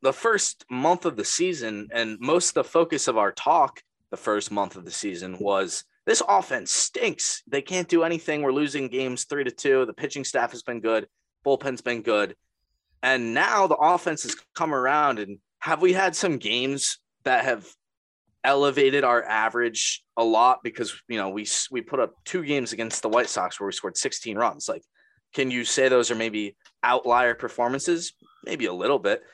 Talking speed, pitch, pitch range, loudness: 190 wpm, 125 Hz, 110-150 Hz, -24 LUFS